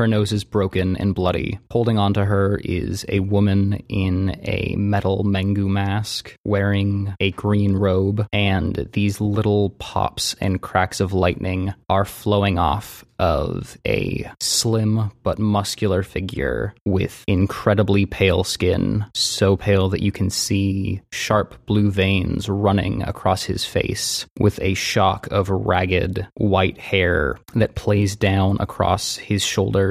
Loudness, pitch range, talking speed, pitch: -20 LUFS, 95-105 Hz, 135 wpm, 100 Hz